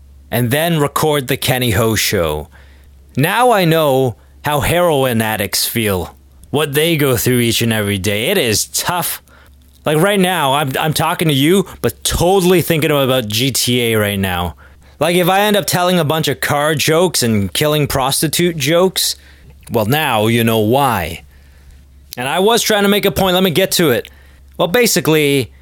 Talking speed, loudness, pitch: 175 wpm, -14 LUFS, 130 Hz